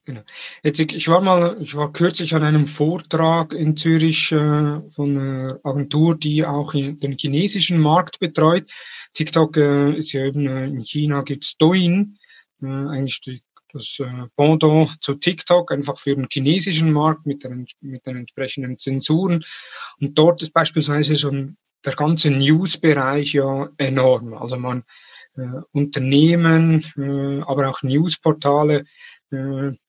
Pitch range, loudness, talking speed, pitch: 135-160 Hz, -18 LUFS, 145 wpm, 150 Hz